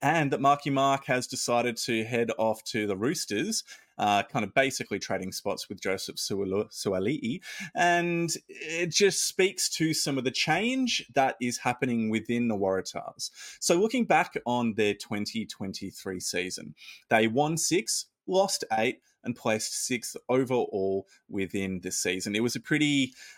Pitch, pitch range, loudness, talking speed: 120 Hz, 110-145 Hz, -28 LUFS, 150 wpm